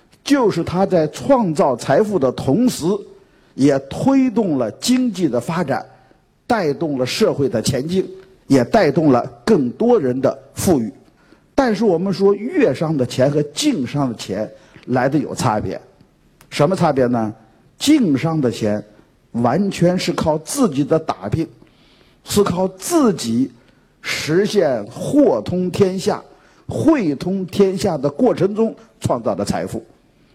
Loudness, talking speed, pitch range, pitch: -18 LUFS, 195 characters per minute, 145-225 Hz, 185 Hz